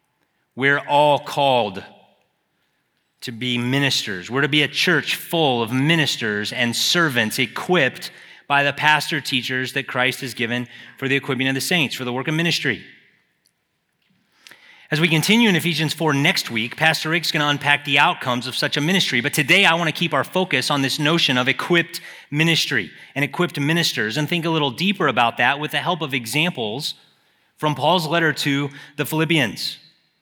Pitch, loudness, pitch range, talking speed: 145 Hz, -19 LUFS, 130-160 Hz, 180 wpm